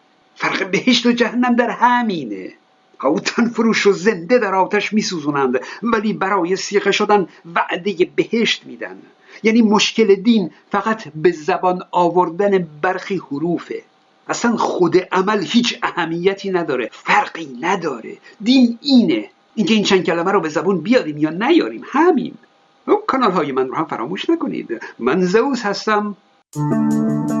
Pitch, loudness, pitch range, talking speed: 205 Hz, -17 LUFS, 180-240 Hz, 135 wpm